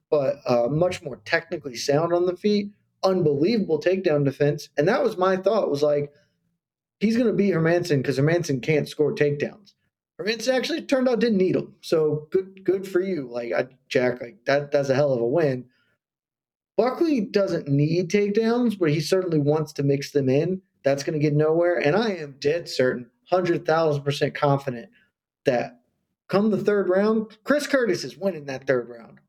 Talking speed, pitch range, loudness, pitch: 185 wpm, 145-195 Hz, -23 LUFS, 165 Hz